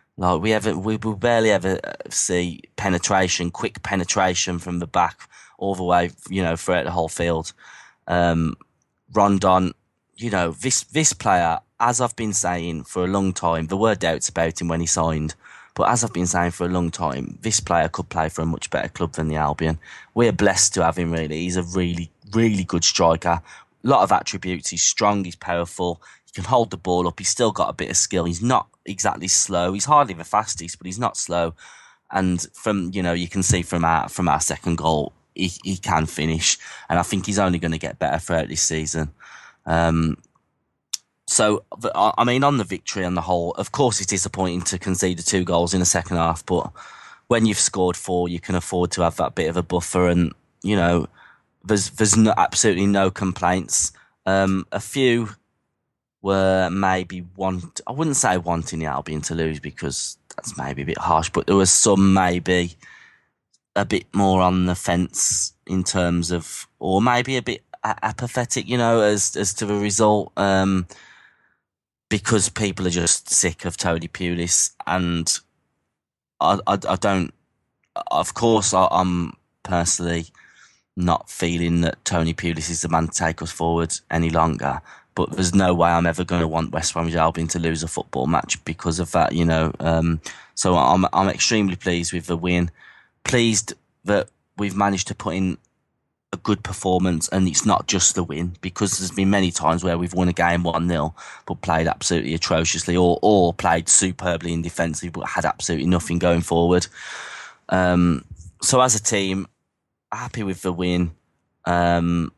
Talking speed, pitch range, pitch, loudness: 185 wpm, 85-95 Hz, 90 Hz, -21 LUFS